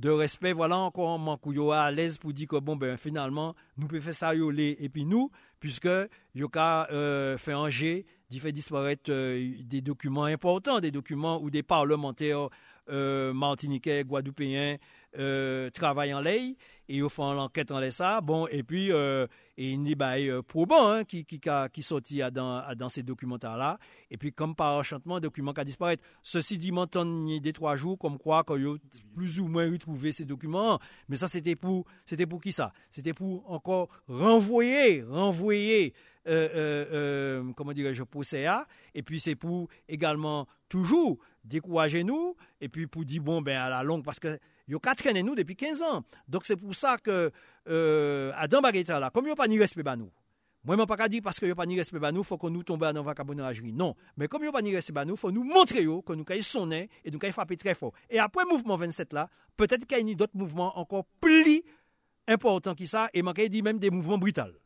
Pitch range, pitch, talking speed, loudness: 145-185 Hz, 160 Hz, 215 wpm, -29 LUFS